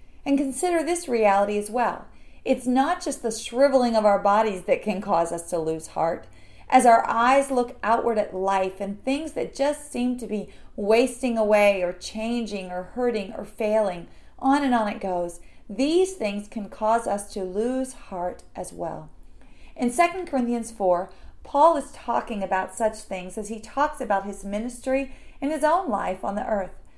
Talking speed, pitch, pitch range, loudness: 180 wpm, 225 Hz, 200-265 Hz, -24 LUFS